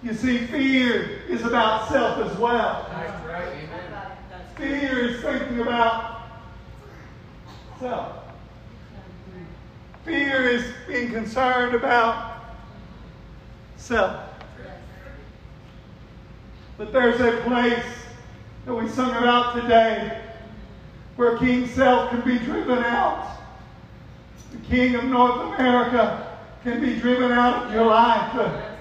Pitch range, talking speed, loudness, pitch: 230-250 Hz, 100 wpm, -22 LUFS, 240 Hz